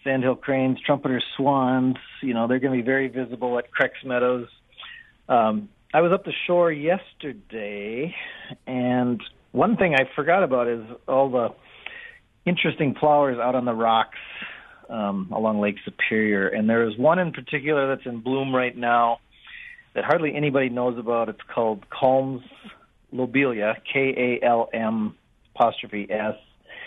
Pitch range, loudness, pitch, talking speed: 115-140 Hz, -23 LUFS, 125 Hz, 145 wpm